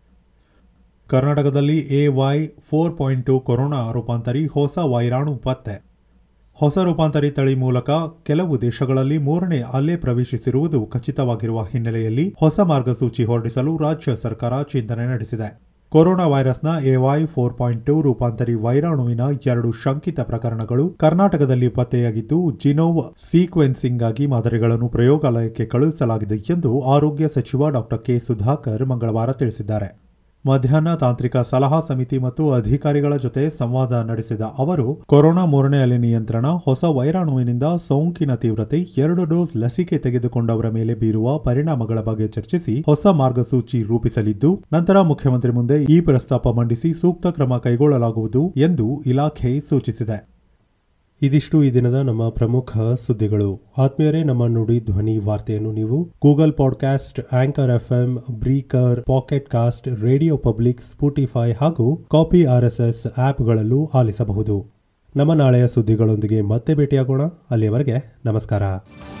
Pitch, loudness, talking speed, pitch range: 130 Hz, -19 LUFS, 115 wpm, 115-145 Hz